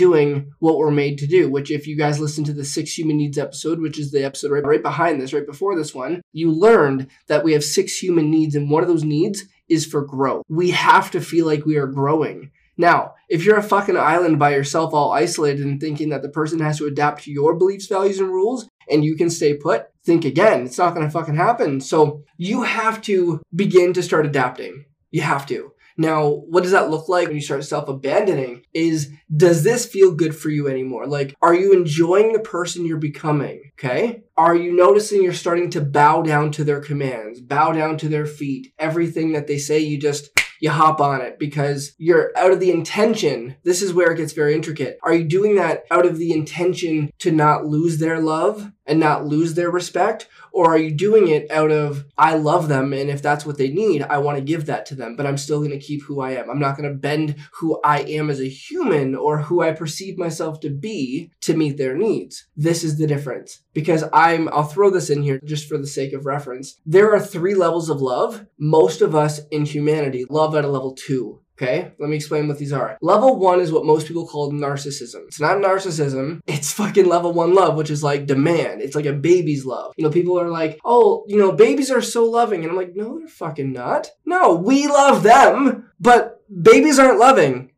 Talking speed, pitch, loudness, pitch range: 225 wpm, 155 Hz, -18 LUFS, 145-180 Hz